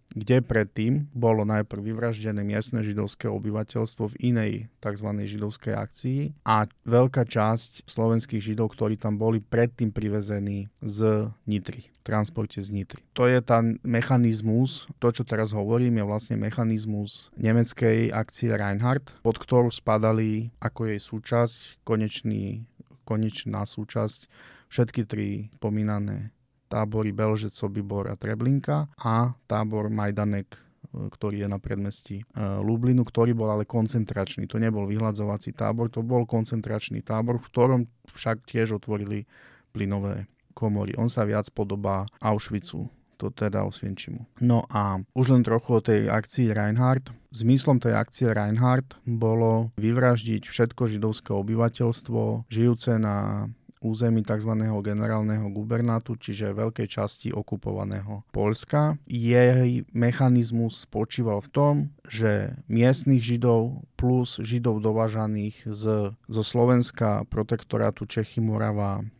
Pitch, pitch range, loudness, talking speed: 110 Hz, 105-120 Hz, -26 LUFS, 120 wpm